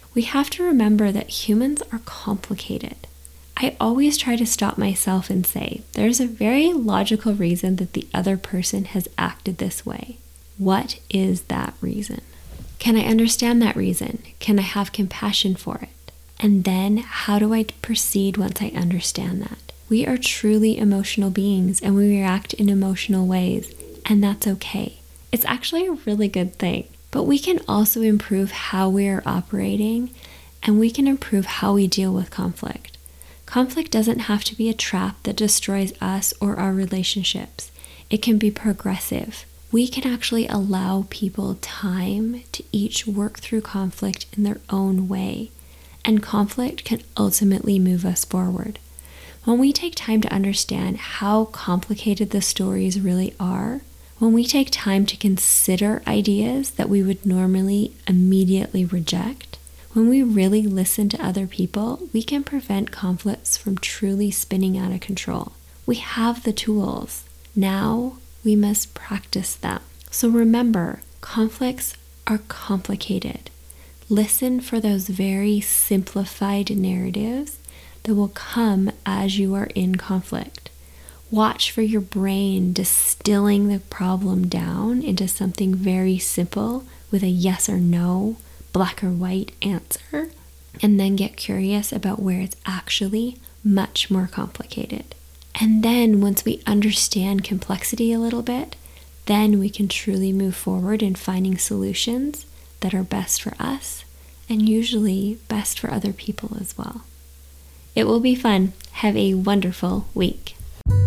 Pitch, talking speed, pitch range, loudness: 200 Hz, 145 wpm, 185-220 Hz, -21 LUFS